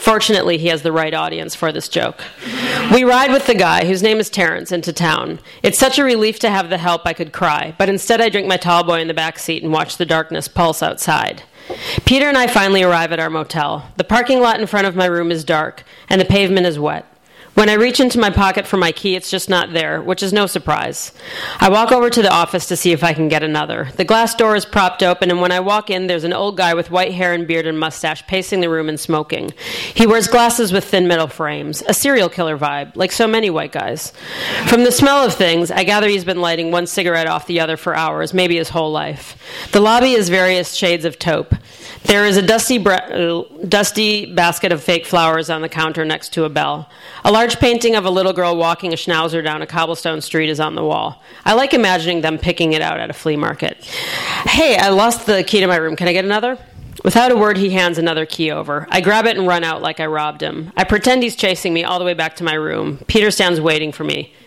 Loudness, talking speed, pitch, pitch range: -15 LUFS, 250 wpm, 180 Hz, 165-210 Hz